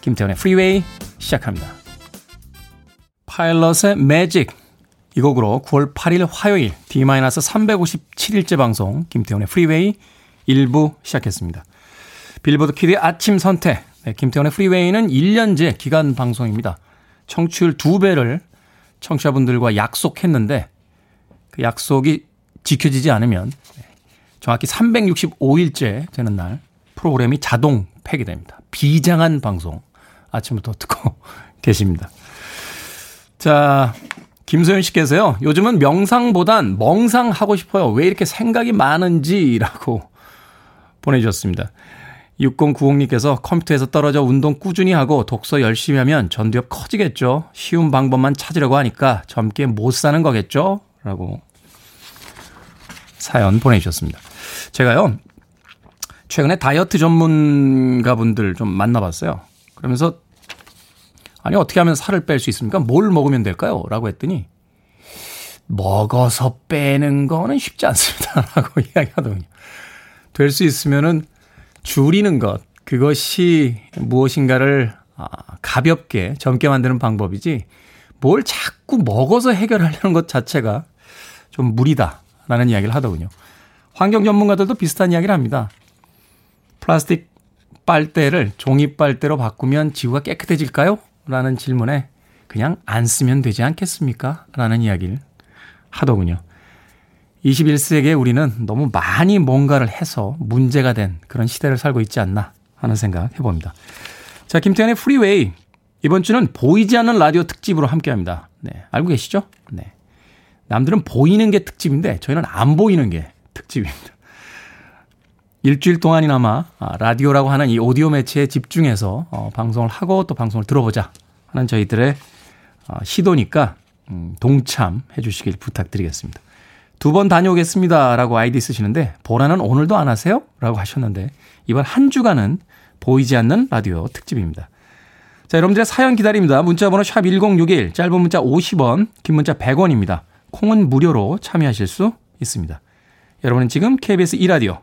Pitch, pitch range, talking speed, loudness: 135 Hz, 110-170 Hz, 295 characters per minute, -16 LUFS